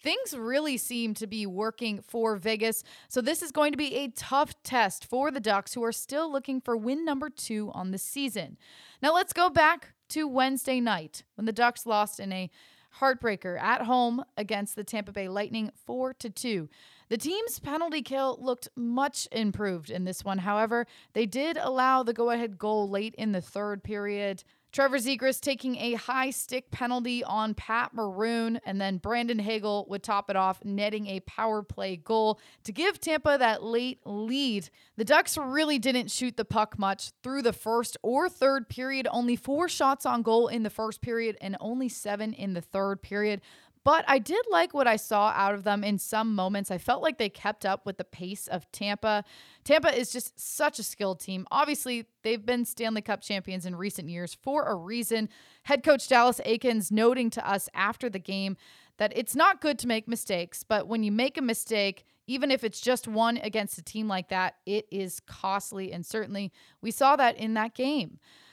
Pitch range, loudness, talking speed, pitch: 205-260 Hz, -29 LUFS, 195 wpm, 225 Hz